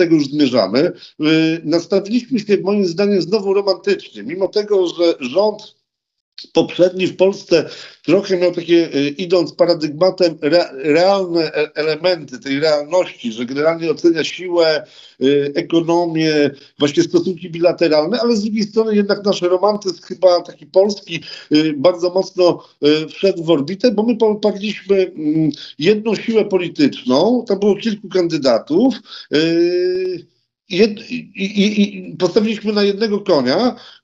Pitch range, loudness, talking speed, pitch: 165-205 Hz, -16 LUFS, 110 wpm, 185 Hz